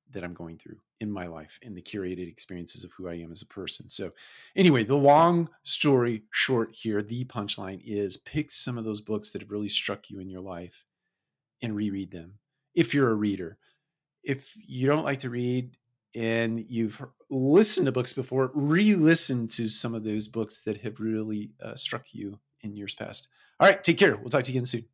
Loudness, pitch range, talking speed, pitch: -27 LUFS, 105-135 Hz, 205 wpm, 115 Hz